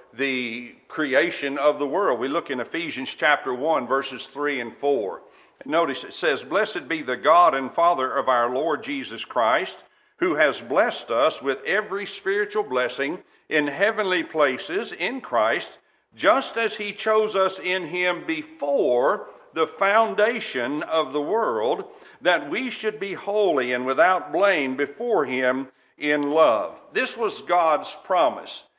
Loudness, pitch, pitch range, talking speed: -23 LUFS, 180 Hz, 140-215 Hz, 150 wpm